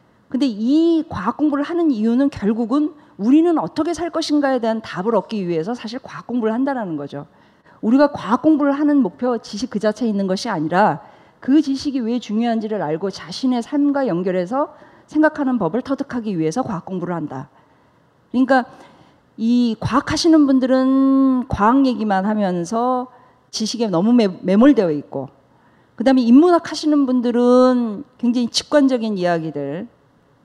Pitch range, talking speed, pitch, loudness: 205-275 Hz, 335 characters per minute, 245 Hz, -18 LUFS